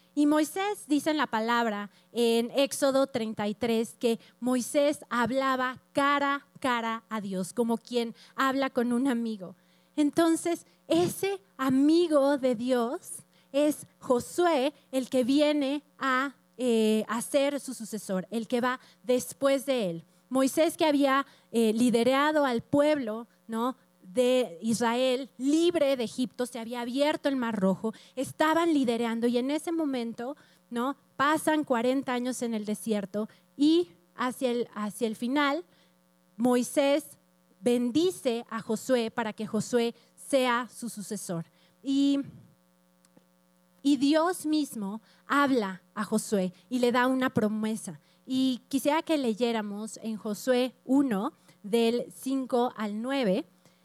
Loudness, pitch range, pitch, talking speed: -28 LUFS, 220-280 Hz, 245 Hz, 130 wpm